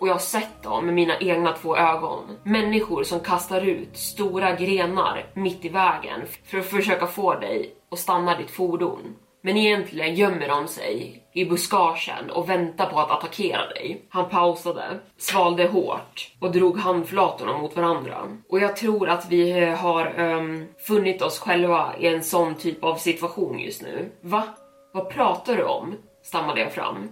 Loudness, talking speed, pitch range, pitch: -23 LUFS, 170 wpm, 170-190 Hz, 180 Hz